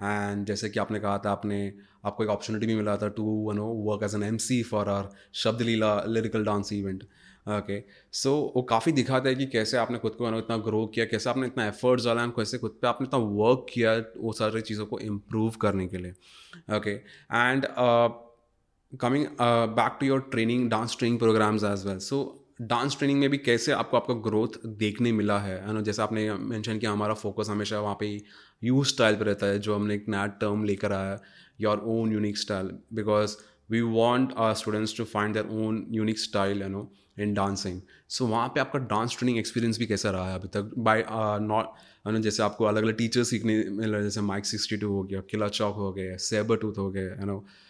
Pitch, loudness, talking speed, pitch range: 110 Hz, -28 LUFS, 215 wpm, 105-115 Hz